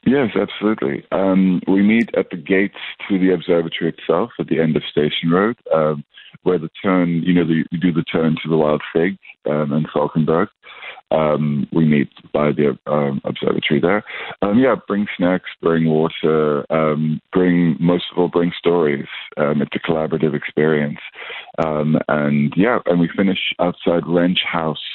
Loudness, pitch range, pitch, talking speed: -18 LUFS, 75-90 Hz, 80 Hz, 170 wpm